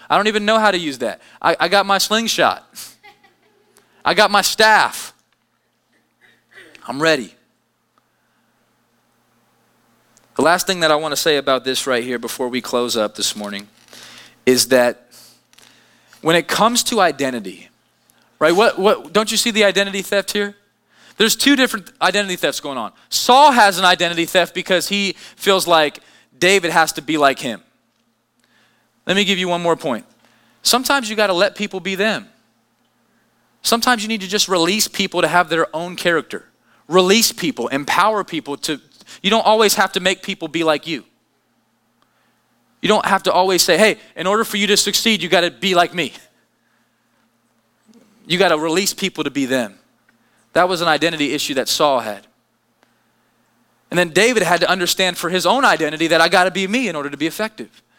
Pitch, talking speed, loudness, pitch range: 180 Hz, 180 wpm, -16 LUFS, 145-205 Hz